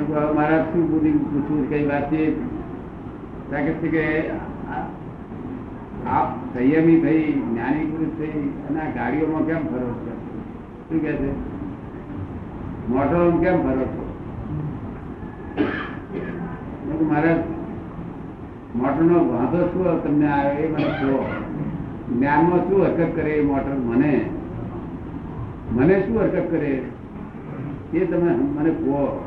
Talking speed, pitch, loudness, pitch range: 55 wpm, 155 Hz, -22 LUFS, 140-160 Hz